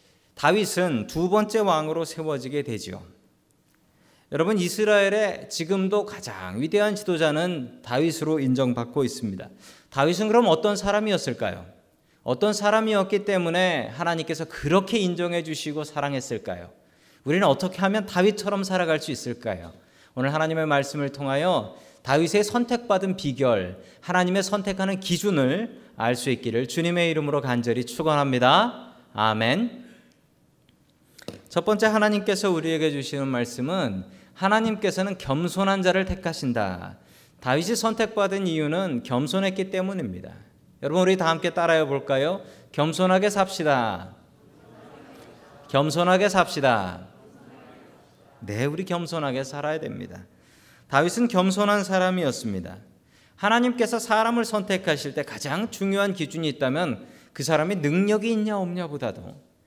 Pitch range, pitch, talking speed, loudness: 140-200 Hz, 170 Hz, 310 characters per minute, -24 LUFS